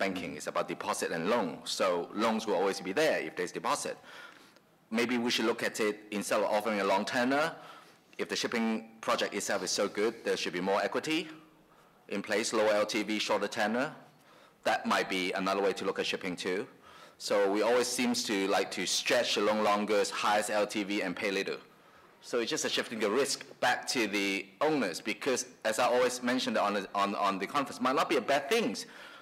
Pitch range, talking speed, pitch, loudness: 100-120 Hz, 210 wpm, 105 Hz, -31 LUFS